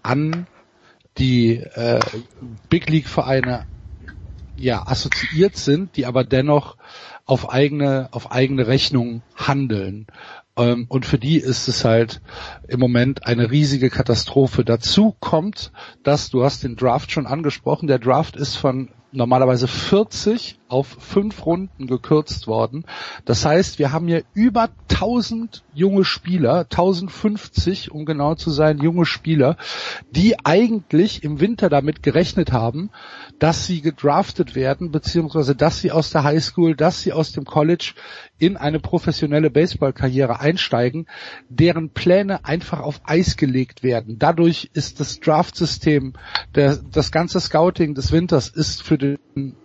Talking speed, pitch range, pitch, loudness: 135 wpm, 130-165 Hz, 145 Hz, -19 LUFS